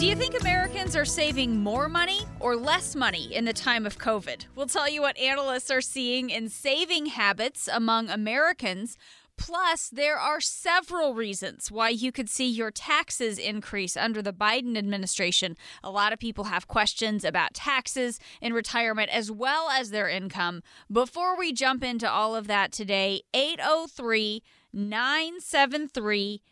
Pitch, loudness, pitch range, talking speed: 235 Hz, -26 LUFS, 210-285 Hz, 155 wpm